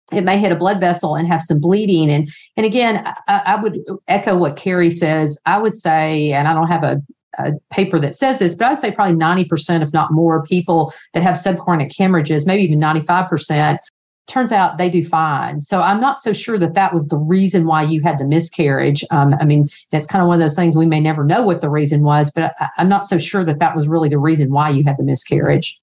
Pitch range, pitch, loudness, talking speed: 155-190 Hz, 165 Hz, -15 LUFS, 250 wpm